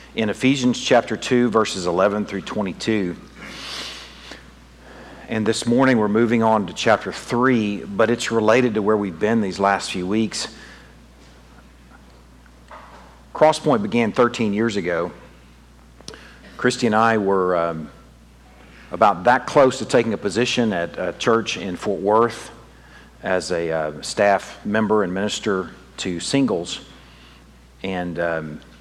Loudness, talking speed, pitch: -20 LUFS, 130 wpm, 95 Hz